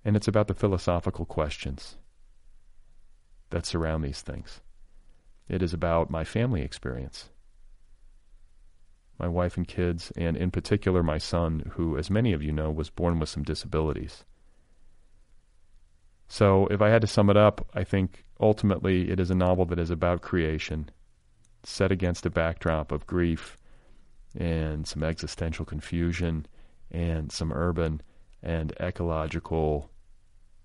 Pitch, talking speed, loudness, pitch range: 85 Hz, 135 wpm, -28 LUFS, 80-95 Hz